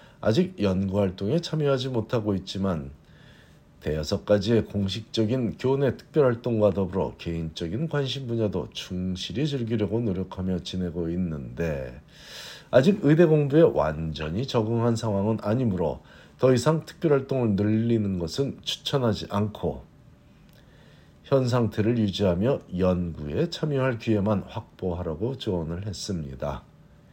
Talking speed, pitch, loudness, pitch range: 290 characters per minute, 105 Hz, -26 LUFS, 90-125 Hz